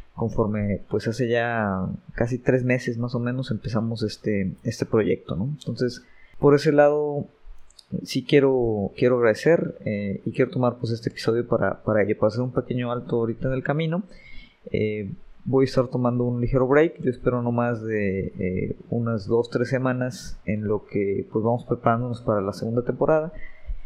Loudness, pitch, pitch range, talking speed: -24 LUFS, 120 Hz, 110-130 Hz, 175 wpm